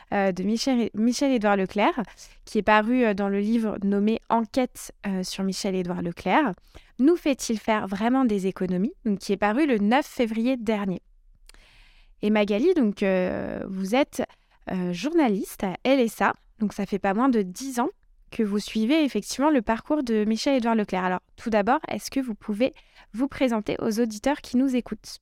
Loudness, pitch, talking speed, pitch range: -25 LUFS, 220 Hz, 165 wpm, 200-260 Hz